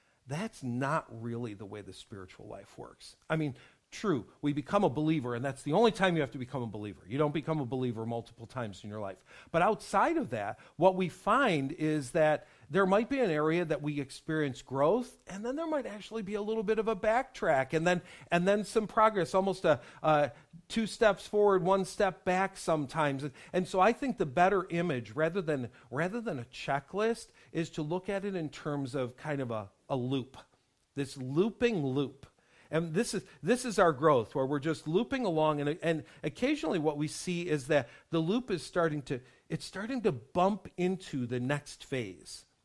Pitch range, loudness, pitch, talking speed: 135-195 Hz, -32 LUFS, 160 Hz, 205 wpm